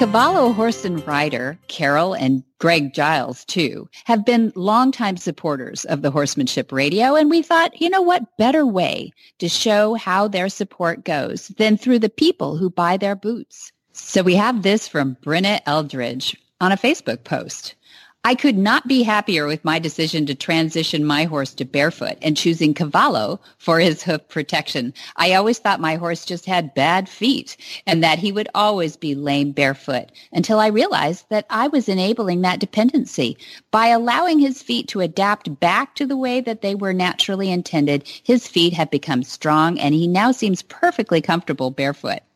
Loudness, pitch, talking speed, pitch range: -19 LUFS, 185 Hz, 175 wpm, 155-230 Hz